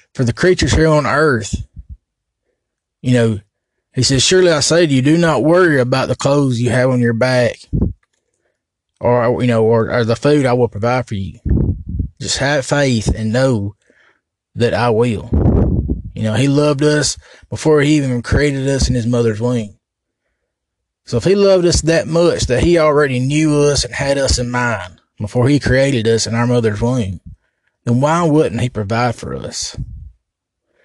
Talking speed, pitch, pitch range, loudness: 180 wpm, 125 Hz, 115-145 Hz, -15 LUFS